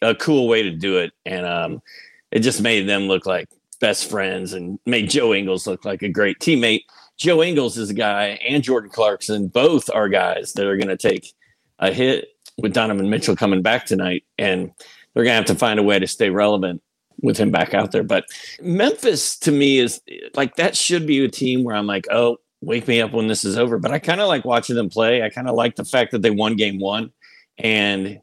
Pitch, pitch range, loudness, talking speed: 115 Hz, 100-135 Hz, -19 LUFS, 230 wpm